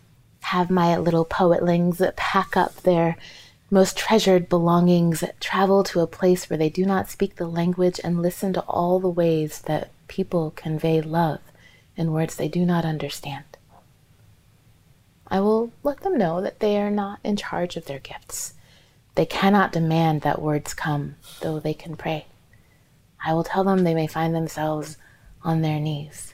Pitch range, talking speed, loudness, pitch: 150-185 Hz, 165 wpm, -23 LUFS, 165 Hz